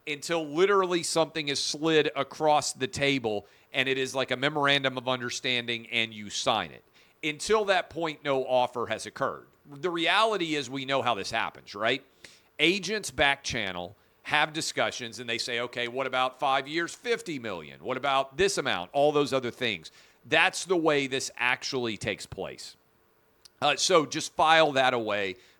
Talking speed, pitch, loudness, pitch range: 170 wpm, 135 Hz, -27 LUFS, 120-155 Hz